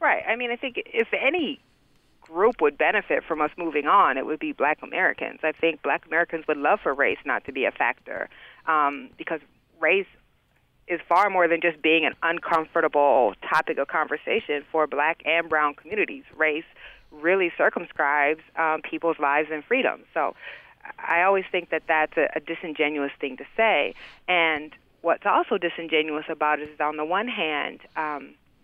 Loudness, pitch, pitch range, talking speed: -24 LUFS, 160 Hz, 150-175 Hz, 175 wpm